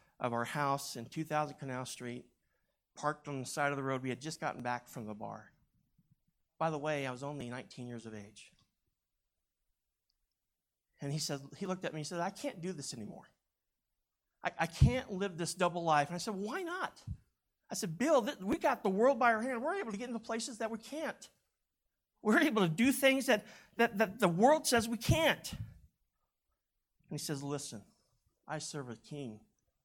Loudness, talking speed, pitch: -35 LUFS, 200 wpm, 155 Hz